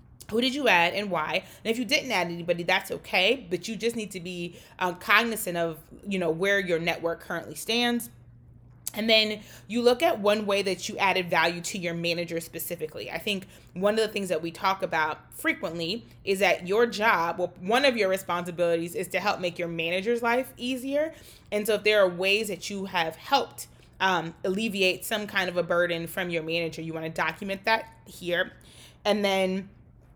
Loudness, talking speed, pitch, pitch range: -26 LUFS, 200 wpm, 185 Hz, 170-215 Hz